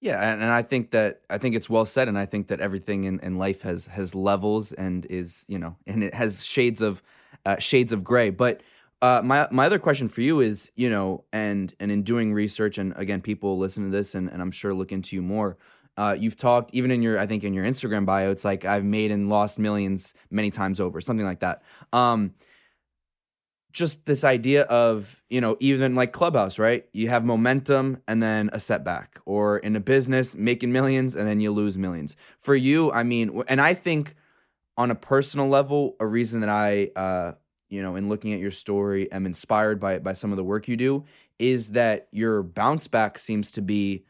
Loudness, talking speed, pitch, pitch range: -24 LUFS, 215 wpm, 105 Hz, 100-120 Hz